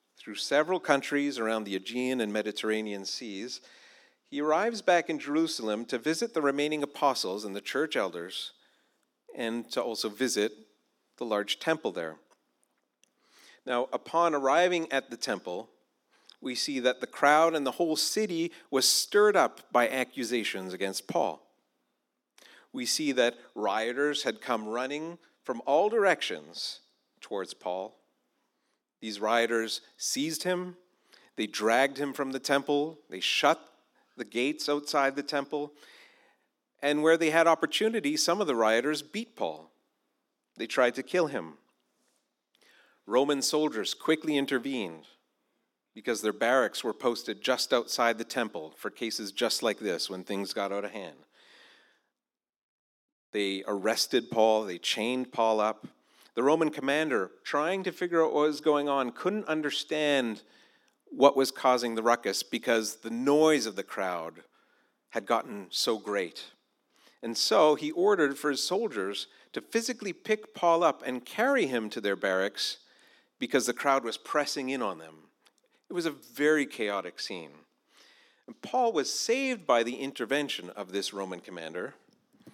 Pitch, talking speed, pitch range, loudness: 140 Hz, 145 wpm, 115-165 Hz, -29 LUFS